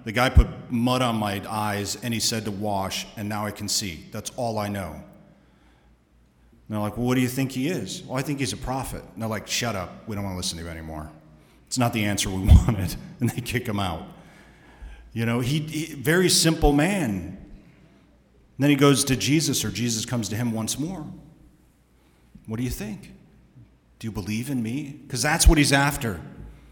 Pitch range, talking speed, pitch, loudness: 100-135 Hz, 215 wpm, 115 Hz, -24 LUFS